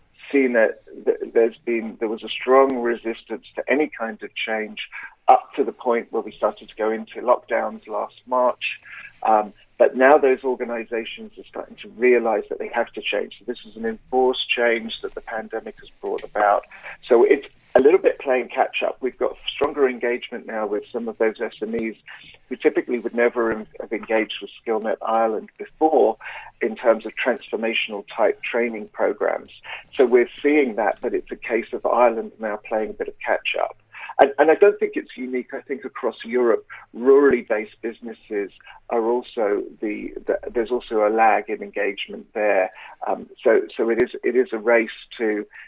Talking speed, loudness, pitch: 185 wpm, -22 LUFS, 130 Hz